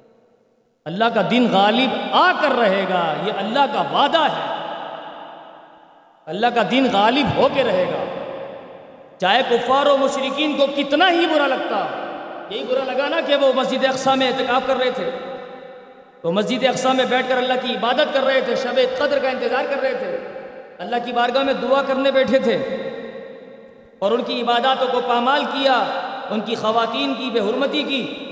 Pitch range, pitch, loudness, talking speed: 245-275 Hz, 260 Hz, -19 LUFS, 180 wpm